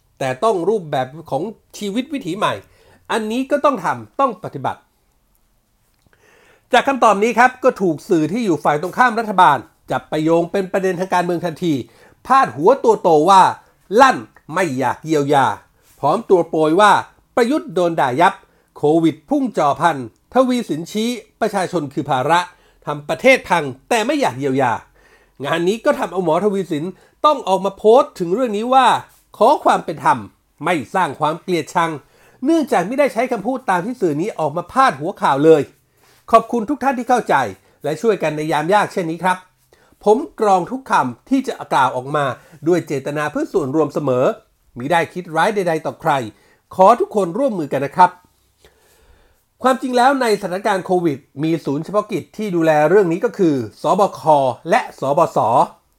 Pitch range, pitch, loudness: 160-245 Hz, 190 Hz, -17 LUFS